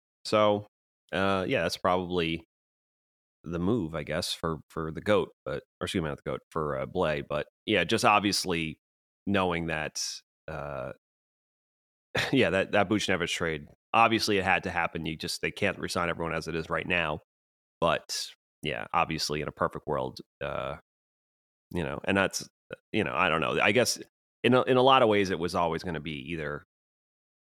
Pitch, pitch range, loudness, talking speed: 85 Hz, 75-95 Hz, -28 LUFS, 185 wpm